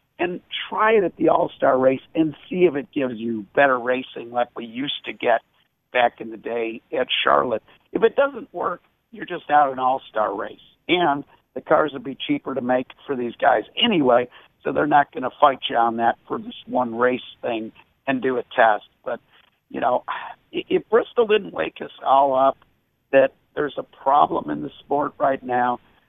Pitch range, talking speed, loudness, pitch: 125-170 Hz, 200 wpm, -22 LUFS, 135 Hz